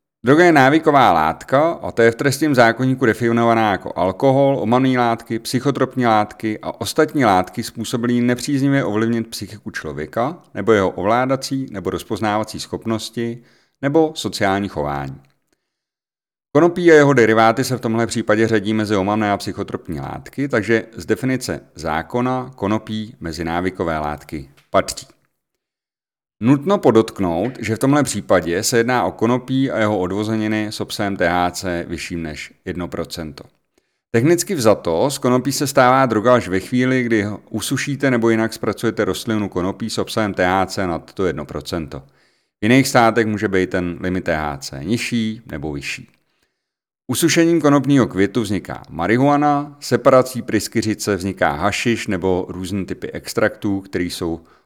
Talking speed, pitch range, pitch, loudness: 135 wpm, 95-125 Hz, 110 Hz, -18 LUFS